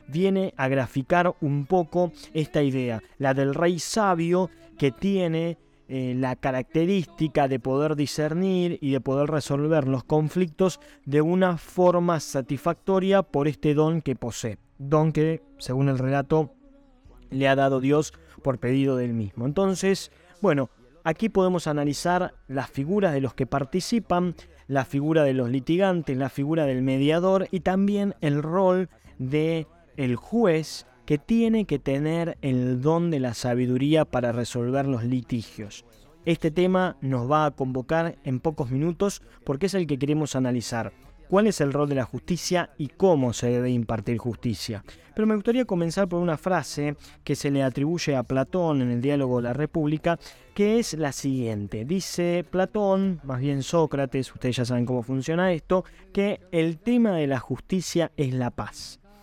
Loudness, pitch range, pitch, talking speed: -25 LUFS, 135-175 Hz, 150 Hz, 160 wpm